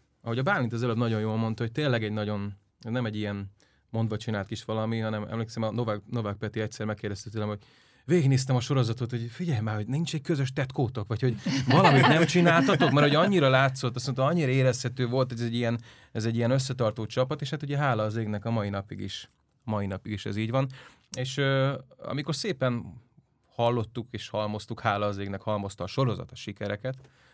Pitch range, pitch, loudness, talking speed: 110-135 Hz, 120 Hz, -28 LUFS, 200 wpm